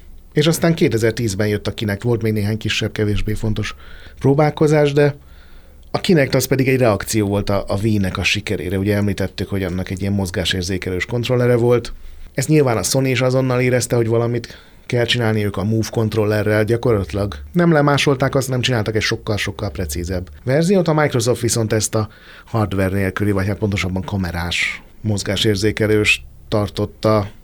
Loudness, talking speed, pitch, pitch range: -18 LUFS, 160 wpm, 110 Hz, 100-120 Hz